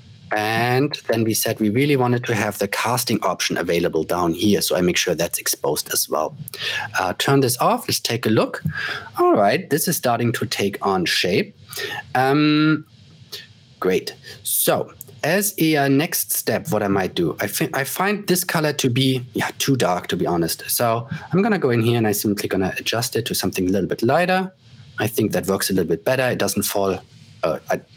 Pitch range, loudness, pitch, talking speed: 115-155 Hz, -20 LUFS, 130 Hz, 205 wpm